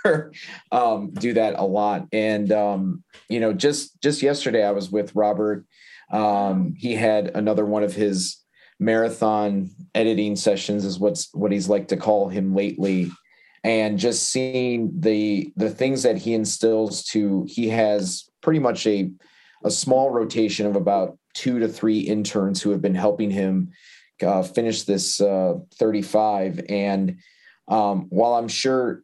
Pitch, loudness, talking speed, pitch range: 105 Hz, -22 LUFS, 155 wpm, 100-115 Hz